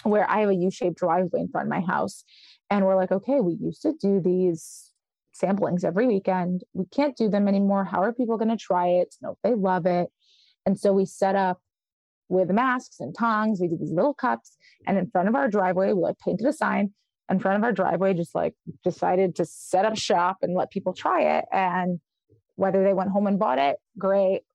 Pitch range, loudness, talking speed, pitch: 180-210 Hz, -24 LUFS, 220 wpm, 195 Hz